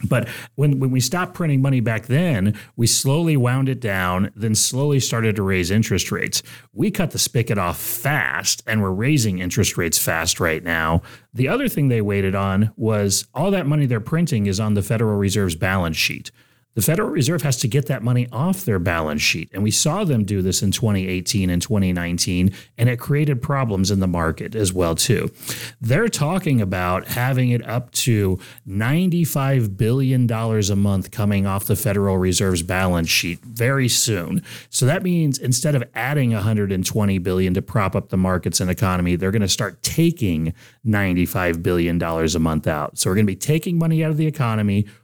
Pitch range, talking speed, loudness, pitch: 95-130 Hz, 190 wpm, -20 LUFS, 110 Hz